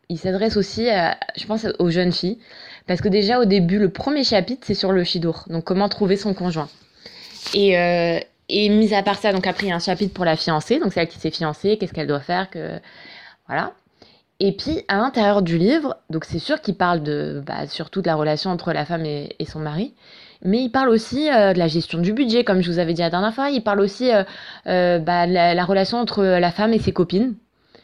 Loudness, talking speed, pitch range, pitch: -20 LUFS, 240 wpm, 170-210 Hz, 190 Hz